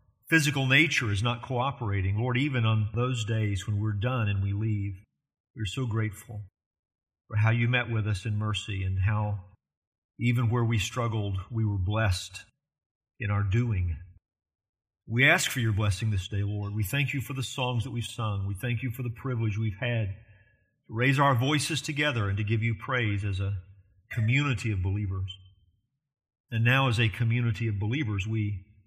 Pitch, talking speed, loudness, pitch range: 110 Hz, 180 wpm, -28 LUFS, 100-120 Hz